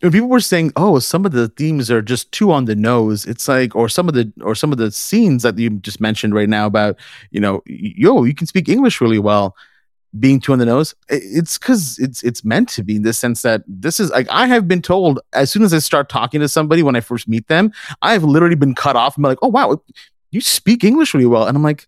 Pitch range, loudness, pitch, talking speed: 115-170 Hz, -15 LUFS, 135 Hz, 265 wpm